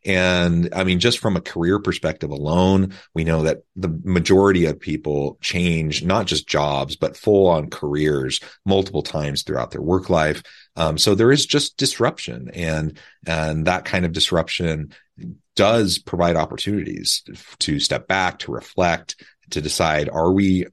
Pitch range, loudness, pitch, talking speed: 80-95 Hz, -20 LUFS, 85 Hz, 155 wpm